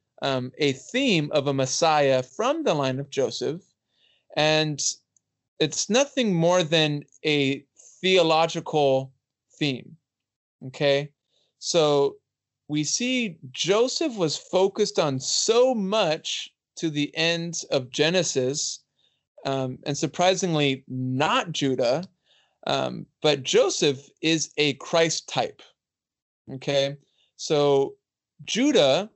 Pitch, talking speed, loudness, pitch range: 150 Hz, 100 wpm, -24 LUFS, 135-170 Hz